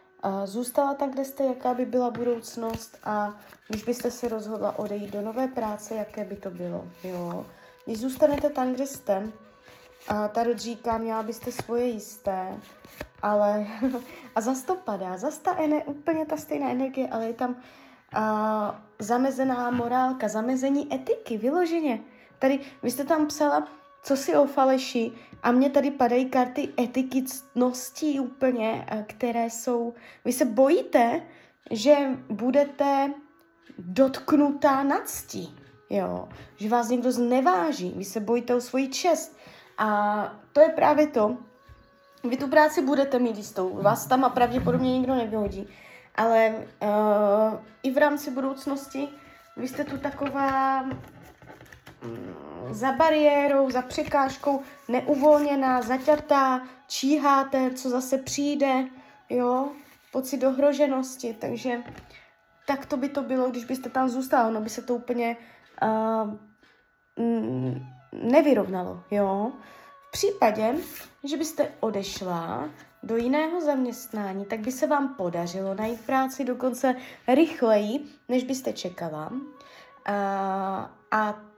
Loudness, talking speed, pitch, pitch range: -26 LUFS, 125 wpm, 255 Hz, 220-280 Hz